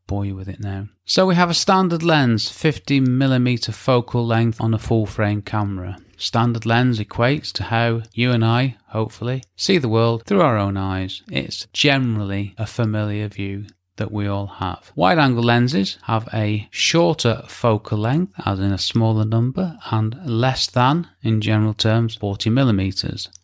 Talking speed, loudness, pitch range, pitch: 165 wpm, -20 LUFS, 100-125 Hz, 115 Hz